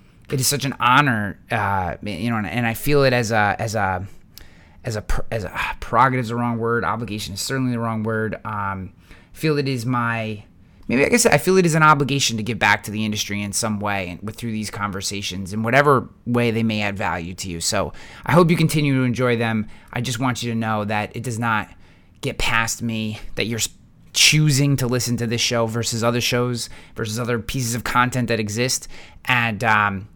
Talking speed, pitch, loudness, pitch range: 220 wpm, 115 Hz, -20 LUFS, 100-125 Hz